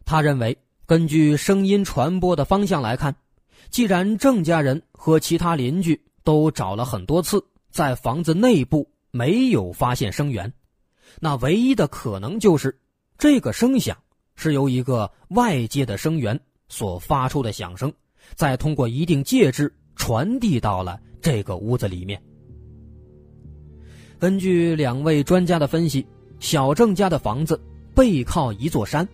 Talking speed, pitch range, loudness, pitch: 215 characters per minute, 125-175 Hz, -21 LUFS, 150 Hz